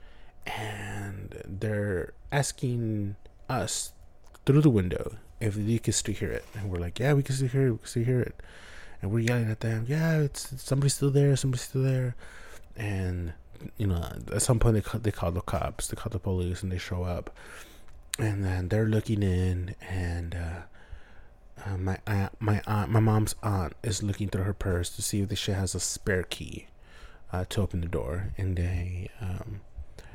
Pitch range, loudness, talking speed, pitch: 90-115 Hz, -29 LUFS, 195 wpm, 105 Hz